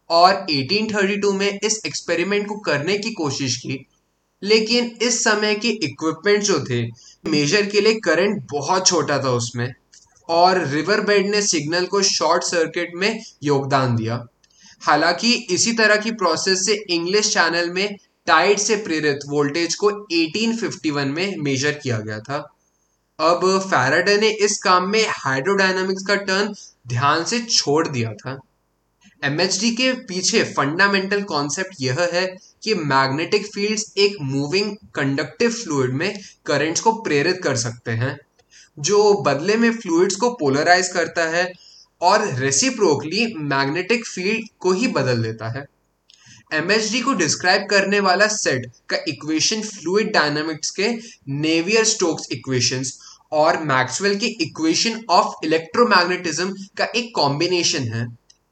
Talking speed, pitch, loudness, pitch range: 135 wpm, 180 Hz, -19 LUFS, 145-205 Hz